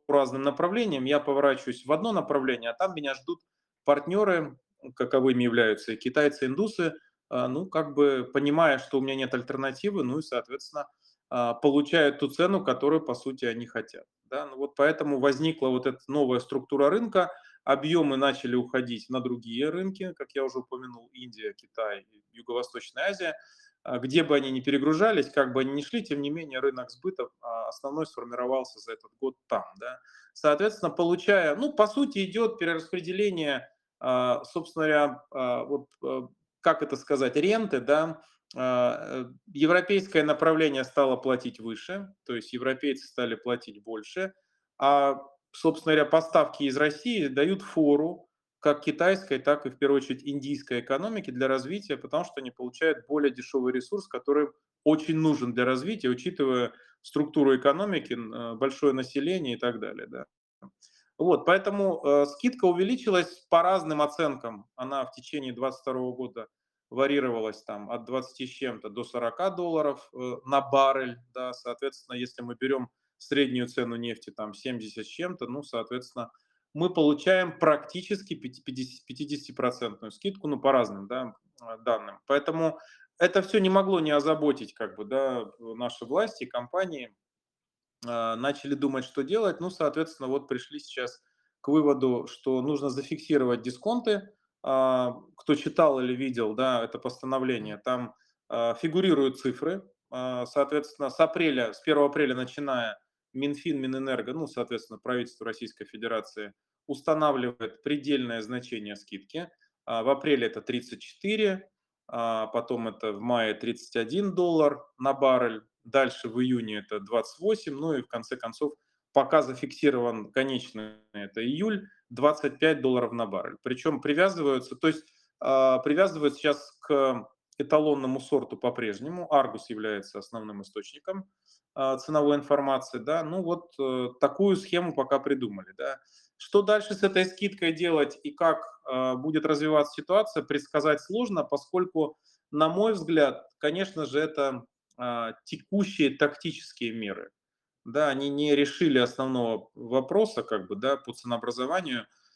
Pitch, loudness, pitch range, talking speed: 140 Hz, -28 LUFS, 125-160 Hz, 135 wpm